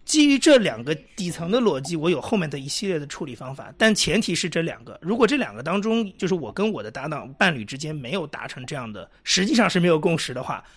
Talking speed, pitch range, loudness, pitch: 370 characters per minute, 150-210 Hz, -22 LUFS, 175 Hz